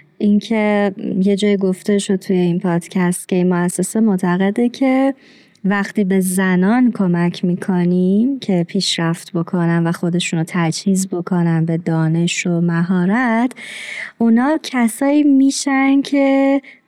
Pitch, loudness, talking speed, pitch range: 195 Hz, -16 LUFS, 115 wpm, 175-235 Hz